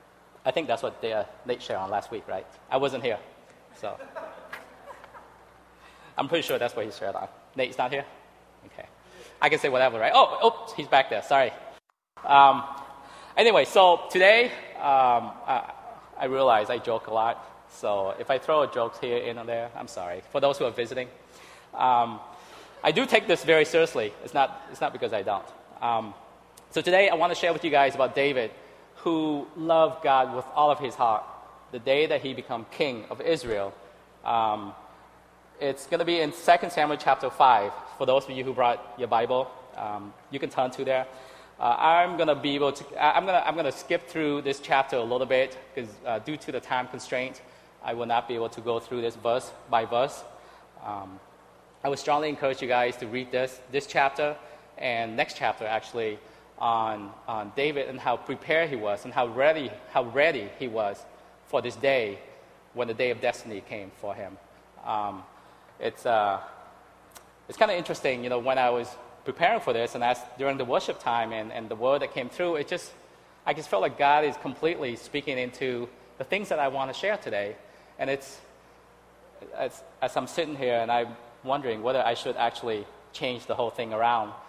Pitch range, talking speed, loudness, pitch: 120-150 Hz, 195 wpm, -26 LUFS, 130 Hz